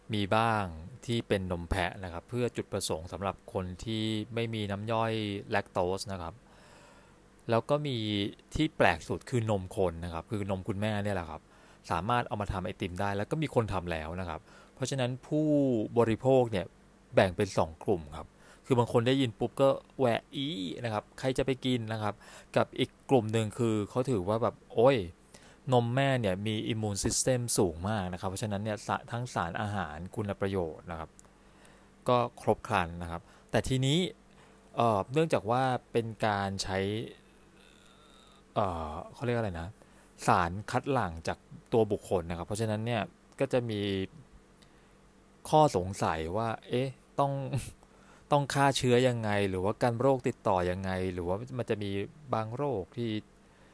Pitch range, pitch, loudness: 95-125 Hz, 110 Hz, -31 LUFS